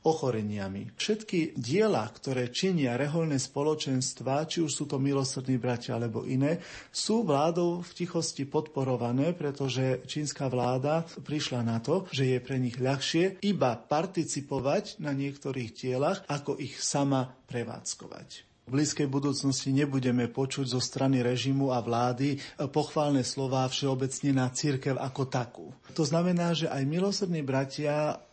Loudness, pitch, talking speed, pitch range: -30 LUFS, 140 Hz, 135 wpm, 130-155 Hz